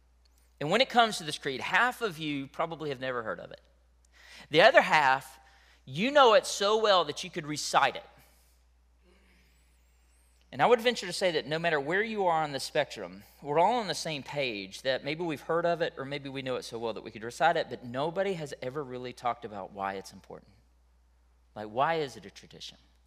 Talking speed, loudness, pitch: 220 wpm, -29 LUFS, 135 Hz